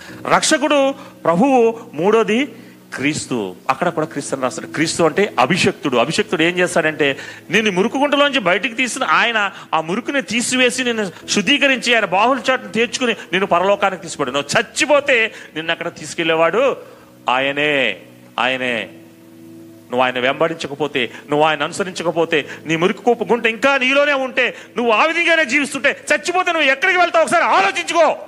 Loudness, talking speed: -16 LUFS, 130 wpm